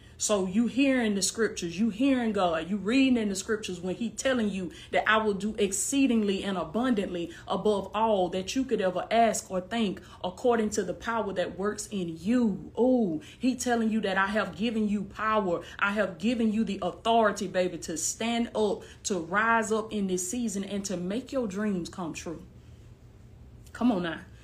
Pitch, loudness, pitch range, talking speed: 210 Hz, -28 LUFS, 190-230 Hz, 190 wpm